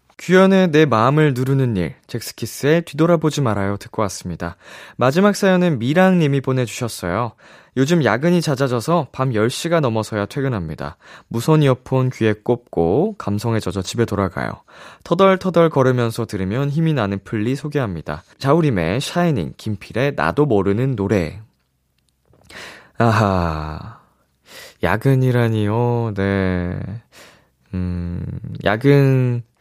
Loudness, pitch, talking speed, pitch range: -18 LUFS, 120 Hz, 280 characters per minute, 100-140 Hz